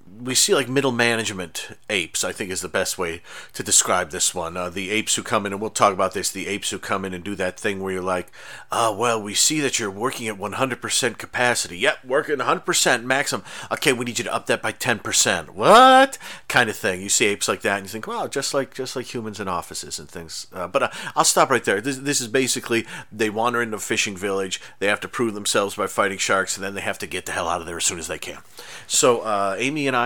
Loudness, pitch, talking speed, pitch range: -21 LUFS, 110 Hz, 260 wpm, 100-130 Hz